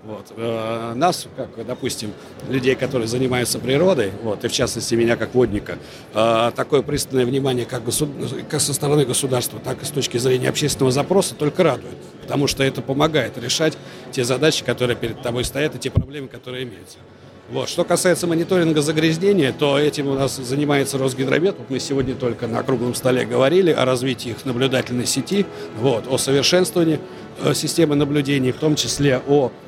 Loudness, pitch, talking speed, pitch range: -20 LUFS, 130 Hz, 165 wpm, 120-145 Hz